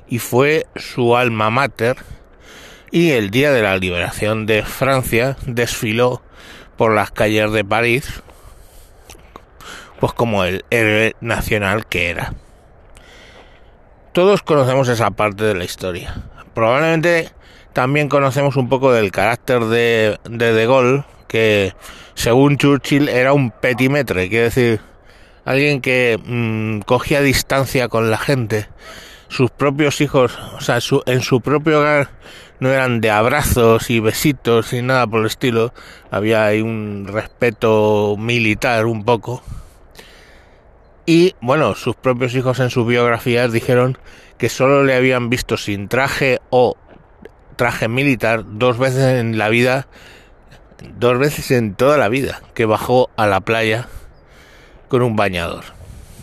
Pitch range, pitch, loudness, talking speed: 110-130 Hz, 120 Hz, -16 LUFS, 135 wpm